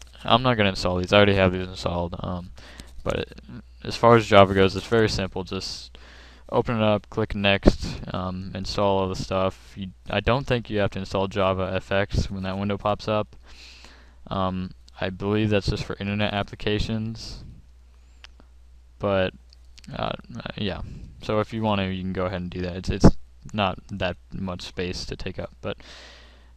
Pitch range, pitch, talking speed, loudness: 70-100 Hz, 95 Hz, 185 wpm, -24 LUFS